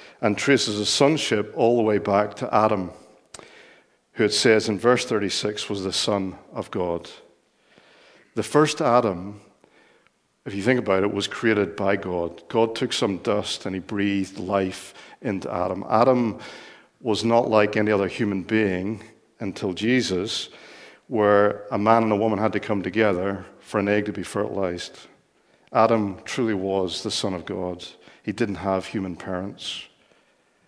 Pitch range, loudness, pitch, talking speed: 95-110 Hz, -23 LUFS, 105 Hz, 160 wpm